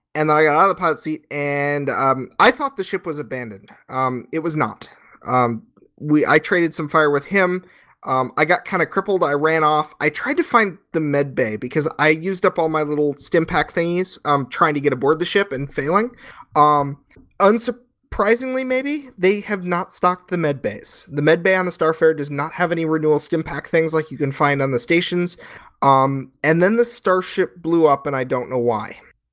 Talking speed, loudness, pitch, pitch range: 220 wpm, -19 LUFS, 160 Hz, 145-185 Hz